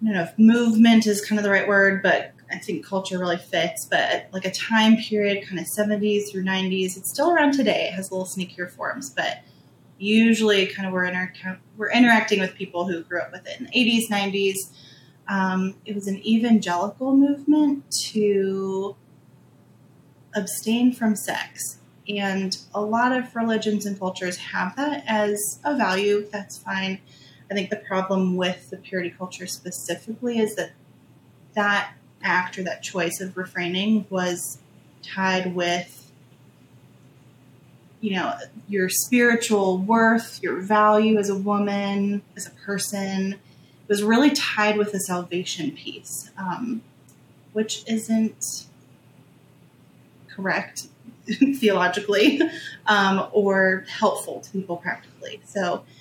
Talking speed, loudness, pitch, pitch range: 145 wpm, -23 LUFS, 195 Hz, 180-215 Hz